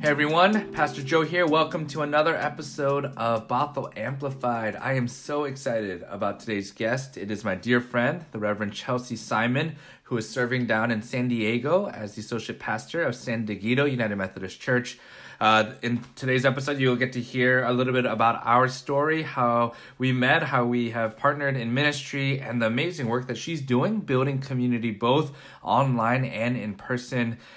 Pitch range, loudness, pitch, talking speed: 115-140 Hz, -25 LUFS, 125 Hz, 180 wpm